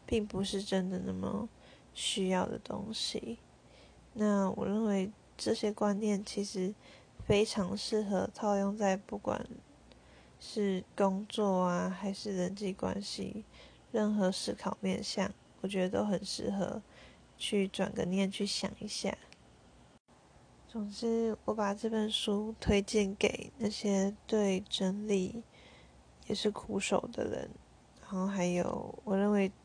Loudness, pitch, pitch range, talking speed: -34 LUFS, 200 Hz, 190-215 Hz, 180 characters per minute